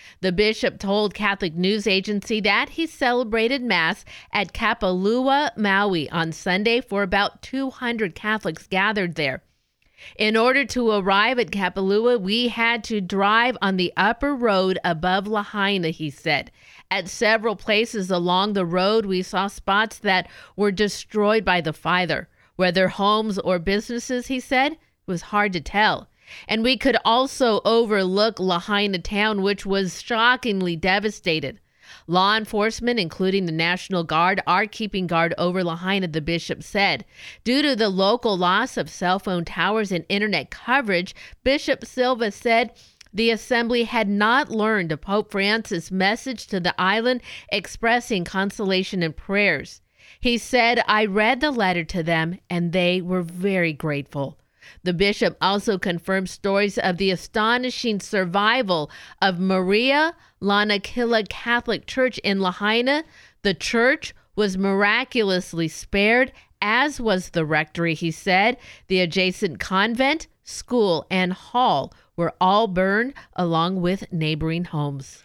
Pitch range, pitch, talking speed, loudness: 185-230 Hz, 200 Hz, 140 wpm, -21 LUFS